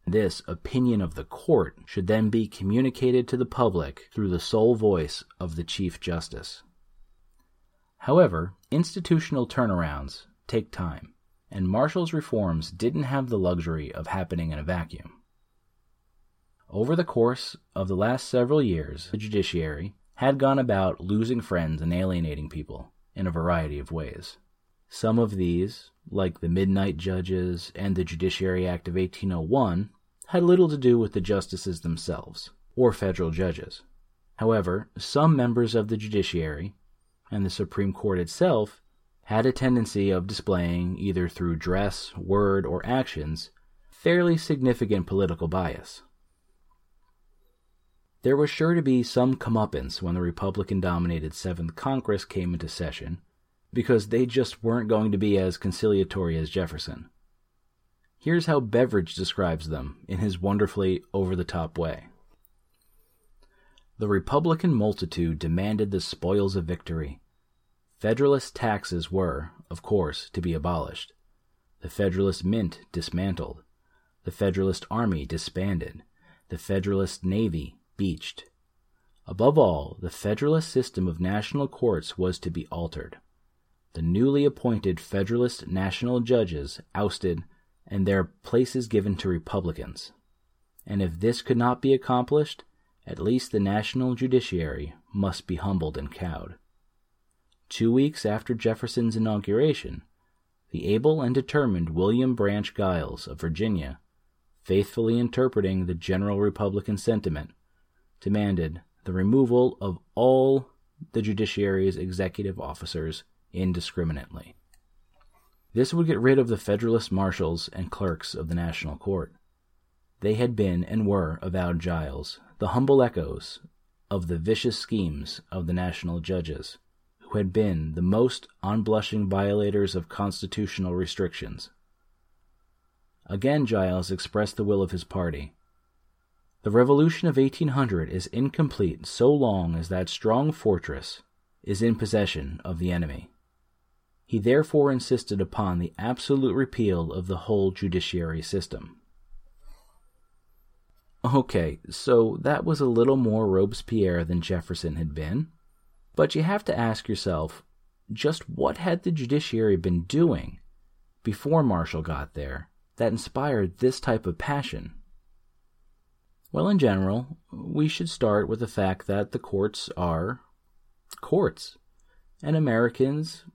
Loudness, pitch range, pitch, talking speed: -26 LUFS, 85-115 Hz, 95 Hz, 130 wpm